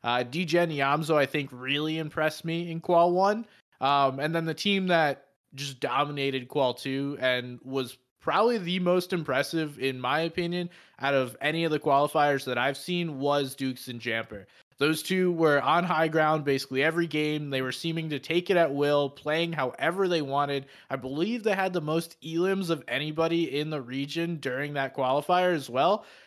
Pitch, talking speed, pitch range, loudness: 150 Hz, 185 wpm, 135-170 Hz, -27 LUFS